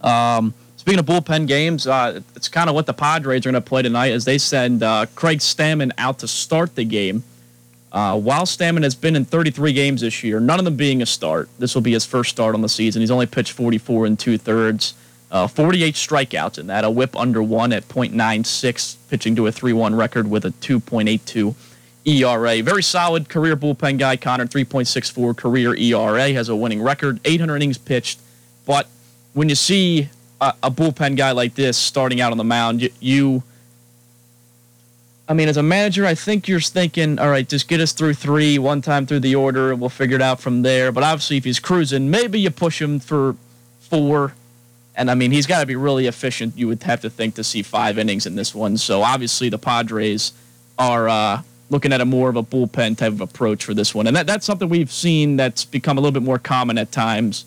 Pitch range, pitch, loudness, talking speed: 115-145 Hz, 125 Hz, -18 LUFS, 215 wpm